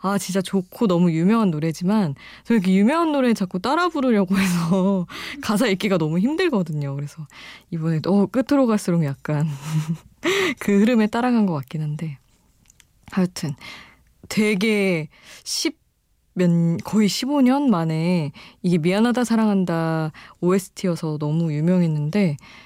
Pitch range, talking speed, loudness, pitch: 165-215 Hz, 280 characters per minute, -21 LUFS, 185 Hz